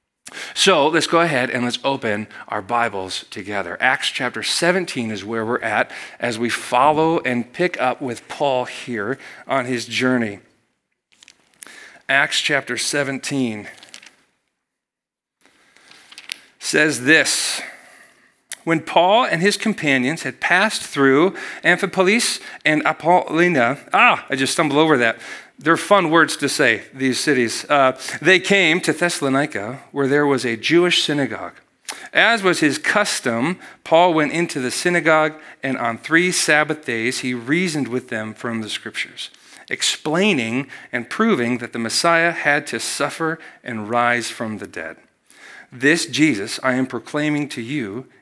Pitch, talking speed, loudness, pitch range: 135 Hz, 140 wpm, -18 LUFS, 120-160 Hz